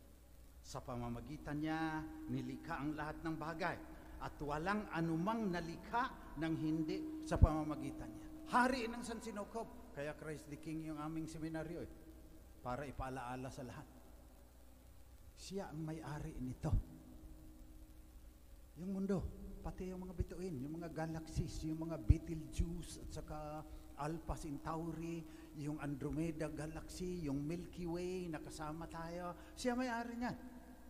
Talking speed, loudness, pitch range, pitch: 125 wpm, -43 LUFS, 135-170 Hz, 155 Hz